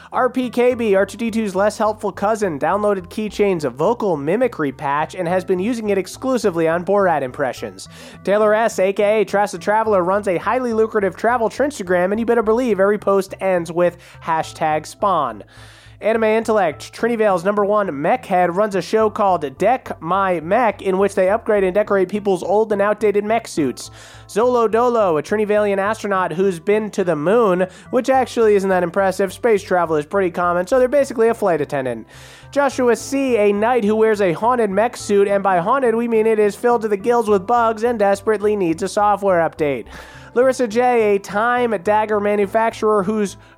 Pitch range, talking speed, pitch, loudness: 185-225 Hz, 180 wpm, 205 Hz, -18 LUFS